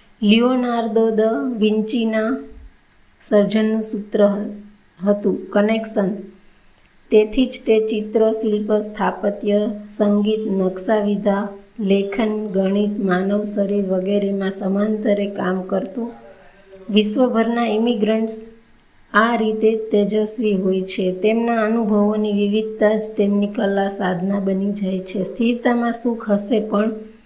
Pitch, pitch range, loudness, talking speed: 210 Hz, 200-220 Hz, -19 LUFS, 95 wpm